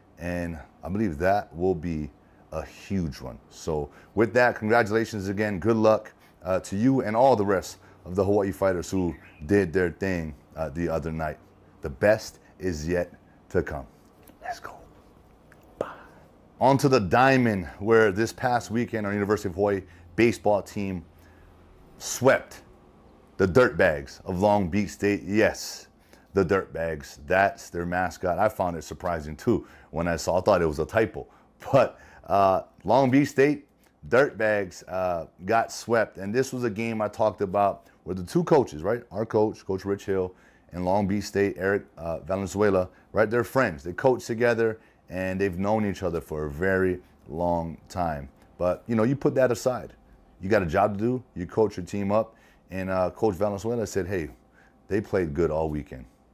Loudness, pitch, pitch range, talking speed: -26 LUFS, 95 Hz, 85-110 Hz, 180 wpm